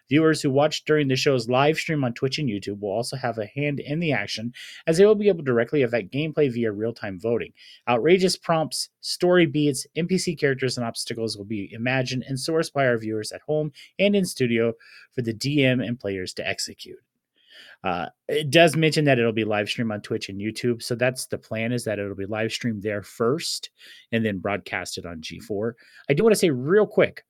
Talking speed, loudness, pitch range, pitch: 215 wpm, -24 LUFS, 110-150 Hz, 125 Hz